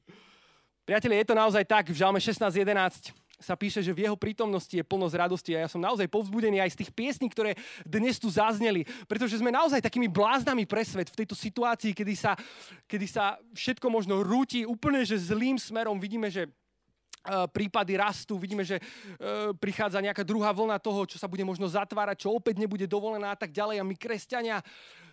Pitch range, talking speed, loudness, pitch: 195-225 Hz, 185 wpm, -29 LUFS, 210 Hz